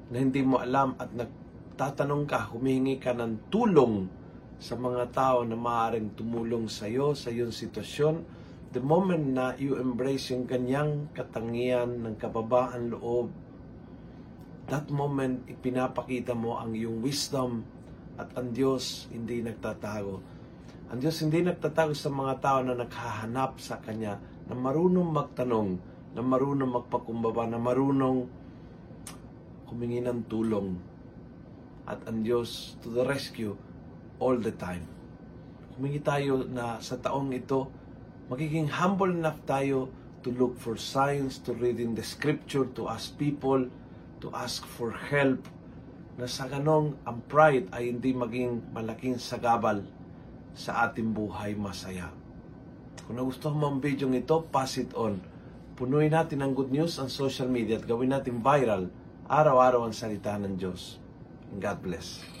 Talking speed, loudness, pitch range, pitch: 140 wpm, -30 LUFS, 115-135 Hz, 125 Hz